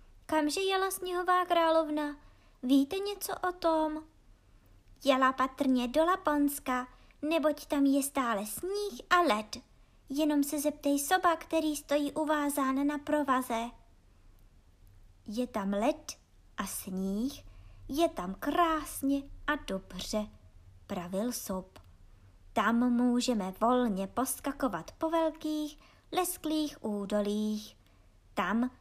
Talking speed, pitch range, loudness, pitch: 100 wpm, 205-310 Hz, -31 LUFS, 275 Hz